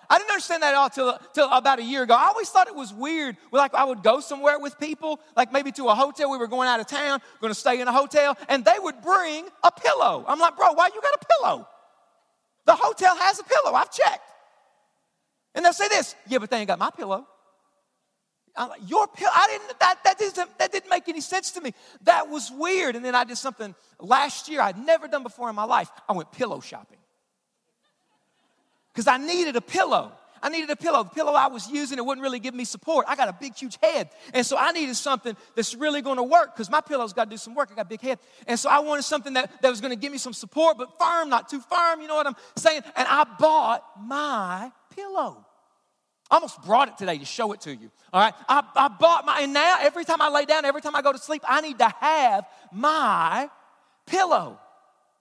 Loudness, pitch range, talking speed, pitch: -23 LUFS, 250-320 Hz, 240 wpm, 280 Hz